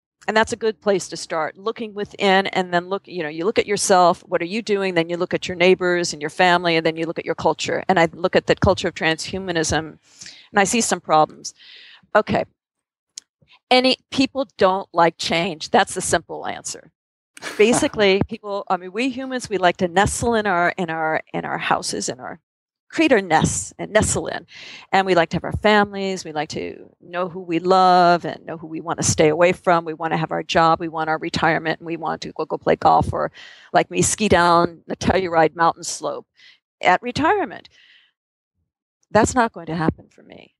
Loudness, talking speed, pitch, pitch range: -20 LUFS, 215 wpm, 180 Hz, 165-200 Hz